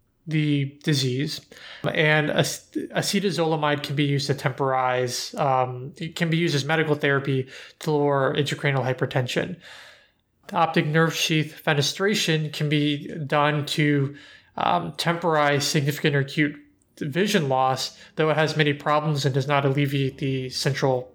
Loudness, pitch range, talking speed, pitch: -23 LUFS, 135-155 Hz, 135 wpm, 145 Hz